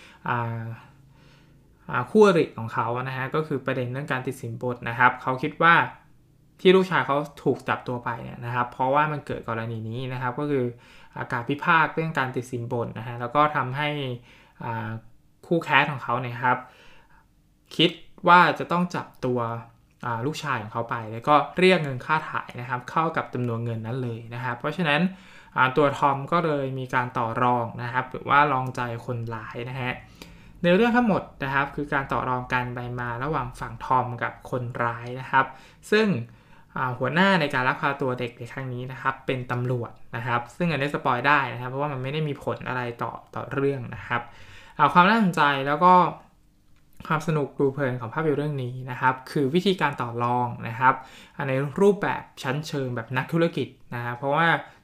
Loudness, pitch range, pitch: -25 LUFS, 125-150 Hz, 130 Hz